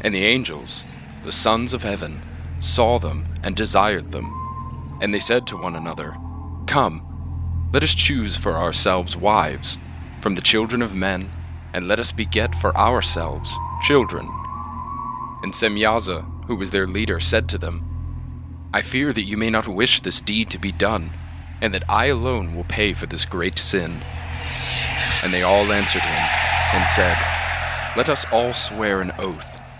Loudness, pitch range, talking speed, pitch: -20 LUFS, 85-100 Hz, 165 wpm, 85 Hz